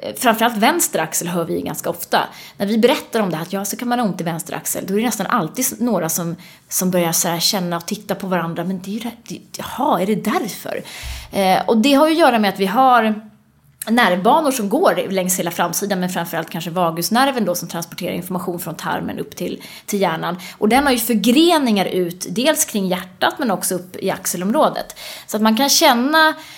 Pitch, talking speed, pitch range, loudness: 200 Hz, 215 wpm, 180-240 Hz, -18 LUFS